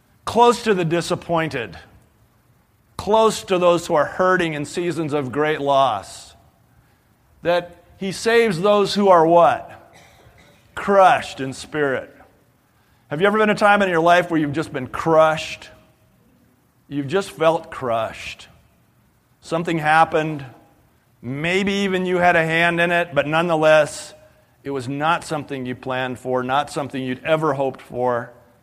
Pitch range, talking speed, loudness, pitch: 140-180 Hz, 145 wpm, -19 LUFS, 160 Hz